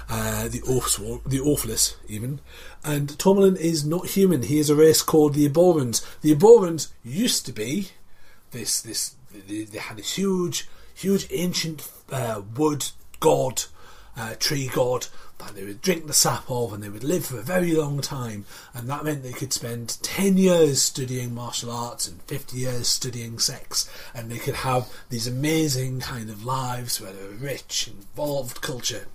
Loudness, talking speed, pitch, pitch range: -23 LUFS, 175 wpm, 130 Hz, 115-155 Hz